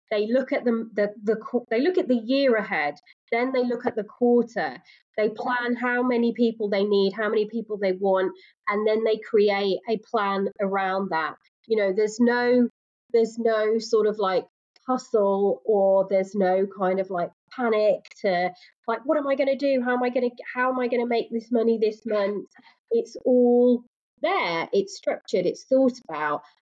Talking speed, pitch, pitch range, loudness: 195 wpm, 225 Hz, 200-245 Hz, -24 LUFS